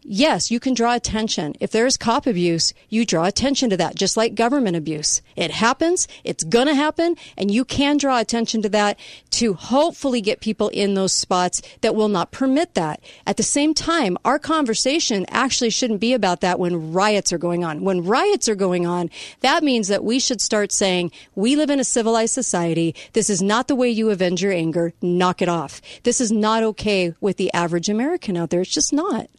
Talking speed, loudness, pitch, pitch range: 210 wpm, -20 LUFS, 220 Hz, 180-255 Hz